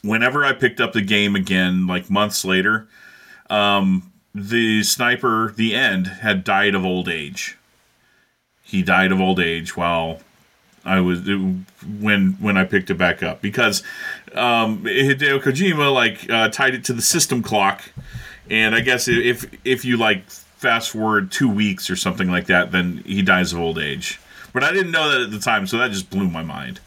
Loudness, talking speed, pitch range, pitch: -18 LUFS, 185 wpm, 95-115 Hz, 100 Hz